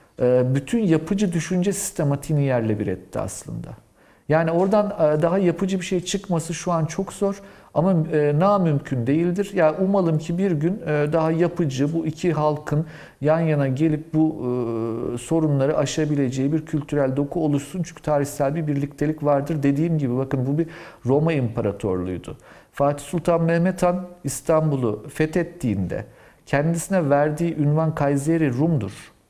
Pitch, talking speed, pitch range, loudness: 155 Hz, 135 wpm, 140-170 Hz, -22 LUFS